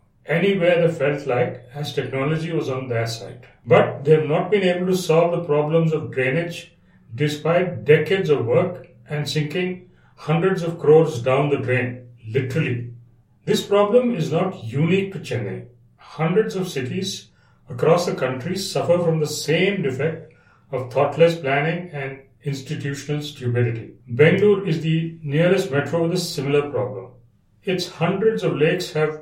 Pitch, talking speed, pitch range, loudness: 155 Hz, 150 wpm, 130-175 Hz, -21 LUFS